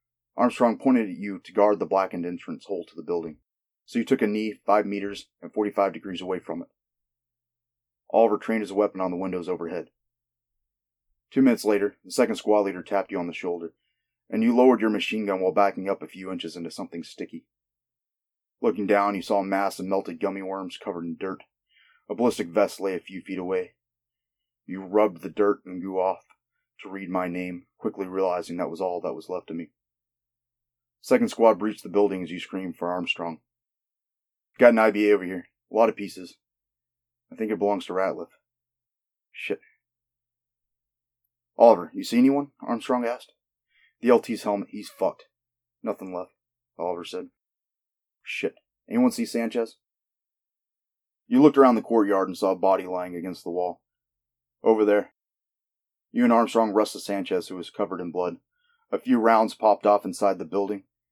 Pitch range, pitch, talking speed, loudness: 90-120 Hz, 100 Hz, 180 wpm, -25 LUFS